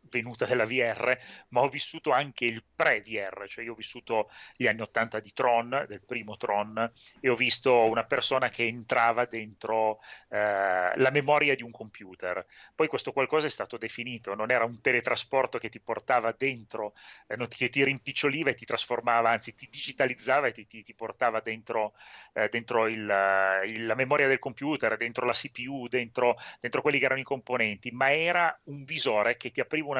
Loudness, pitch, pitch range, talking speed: -28 LUFS, 120 Hz, 110-135 Hz, 180 wpm